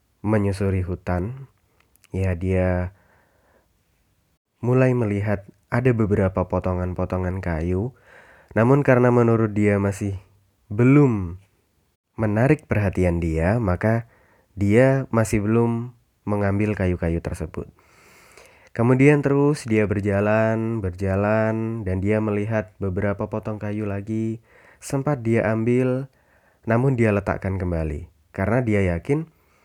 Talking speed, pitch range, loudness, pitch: 95 wpm, 95-115 Hz, -22 LUFS, 105 Hz